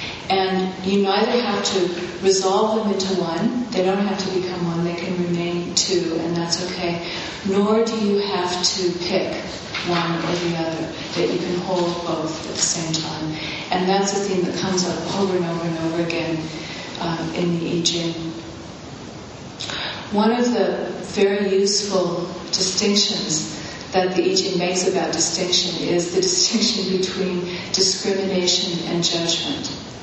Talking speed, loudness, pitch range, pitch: 155 wpm, -21 LUFS, 170-195 Hz, 180 Hz